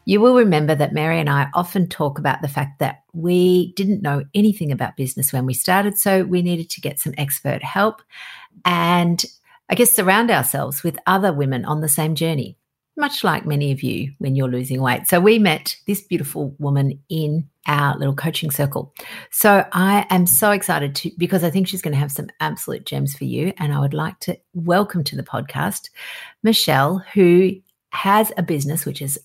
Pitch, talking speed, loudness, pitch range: 170 Hz, 195 wpm, -19 LUFS, 145-195 Hz